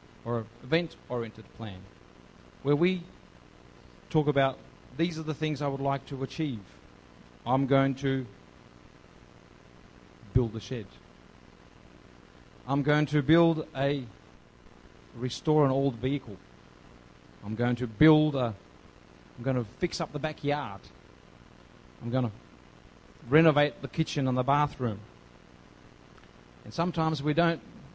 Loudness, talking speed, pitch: -29 LUFS, 120 wpm, 110 Hz